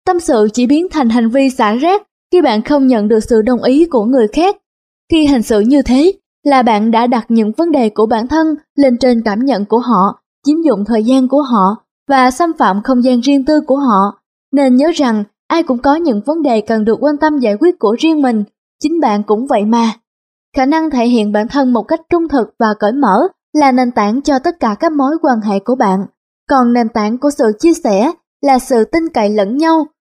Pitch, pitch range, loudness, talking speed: 260 Hz, 225-300 Hz, -12 LUFS, 235 wpm